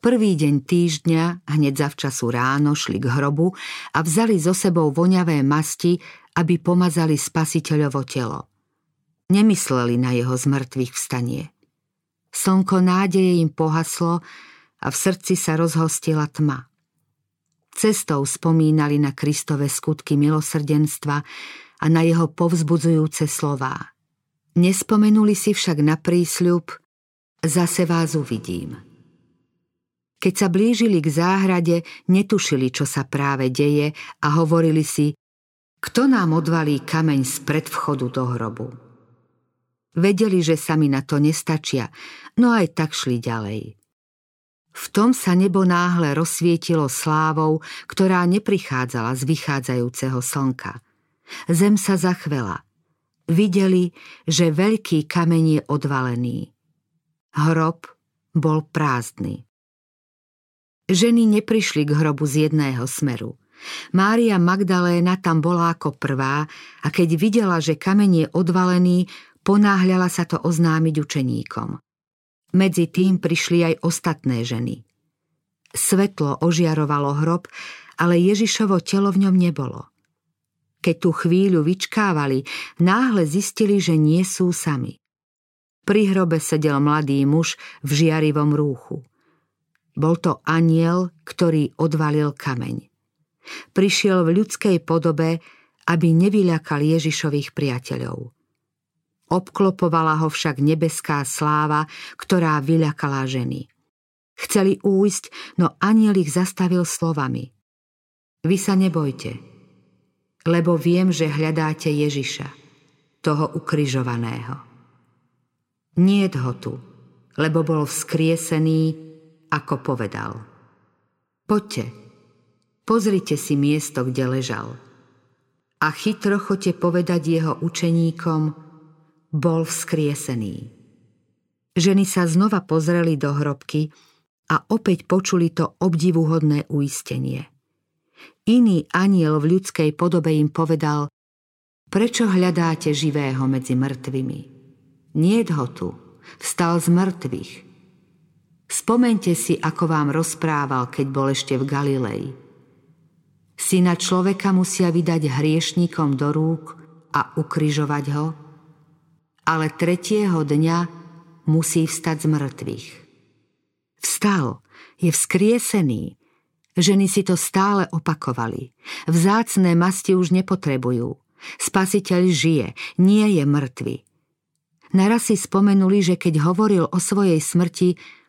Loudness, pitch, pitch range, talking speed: -20 LUFS, 160 Hz, 145-180 Hz, 105 wpm